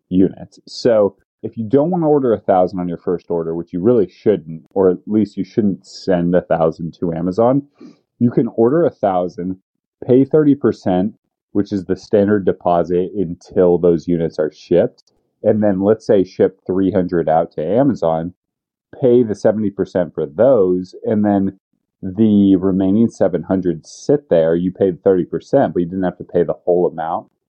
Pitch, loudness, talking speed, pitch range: 95 Hz, -17 LUFS, 170 wpm, 90-110 Hz